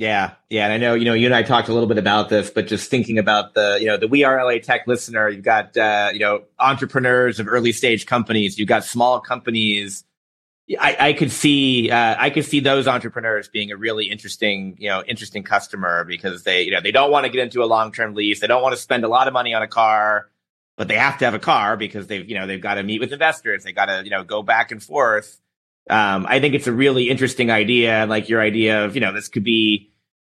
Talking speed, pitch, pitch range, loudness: 255 wpm, 115 Hz, 105-125 Hz, -18 LUFS